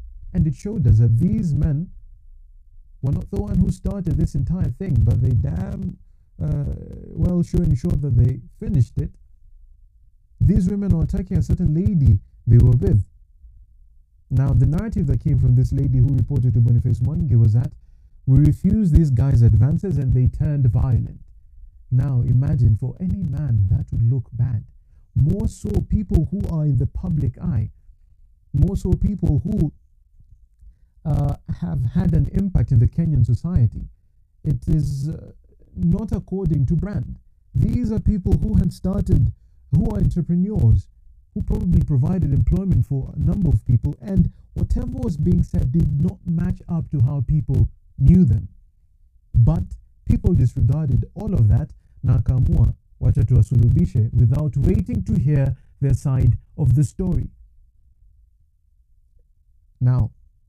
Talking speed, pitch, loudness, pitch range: 145 wpm, 120 Hz, -20 LUFS, 90-140 Hz